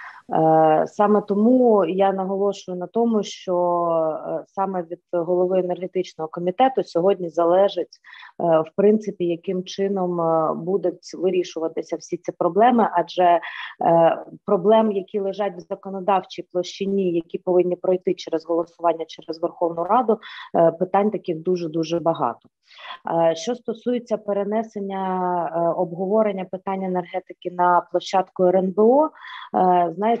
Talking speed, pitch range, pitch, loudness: 105 wpm, 175-200 Hz, 185 Hz, -21 LUFS